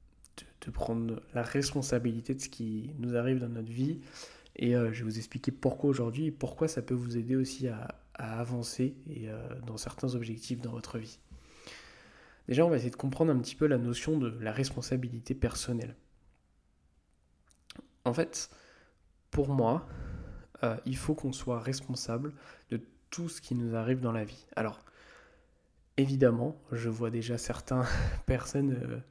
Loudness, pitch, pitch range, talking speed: -34 LUFS, 120 Hz, 115-135 Hz, 165 wpm